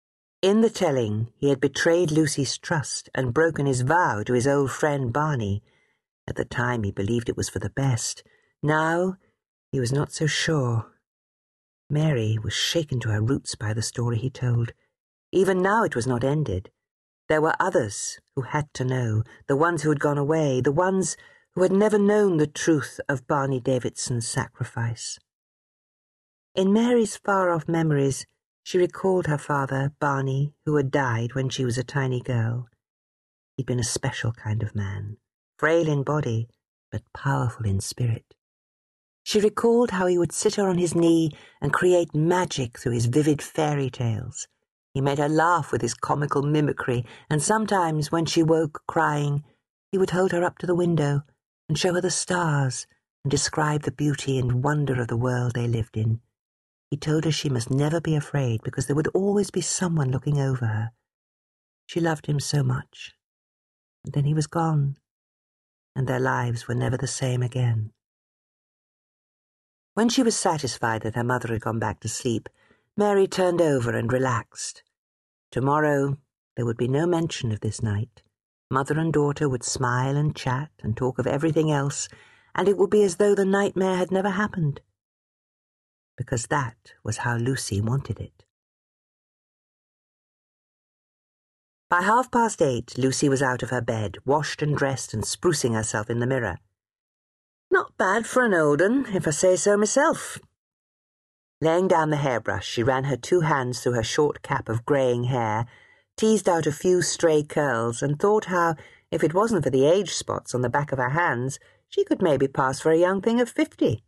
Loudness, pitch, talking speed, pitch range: -24 LUFS, 140 Hz, 175 wpm, 120-165 Hz